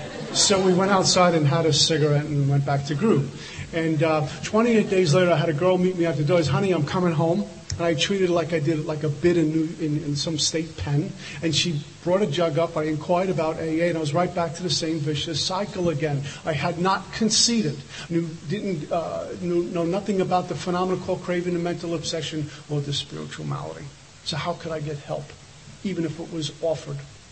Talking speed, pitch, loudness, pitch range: 225 wpm, 165 Hz, -23 LUFS, 155-180 Hz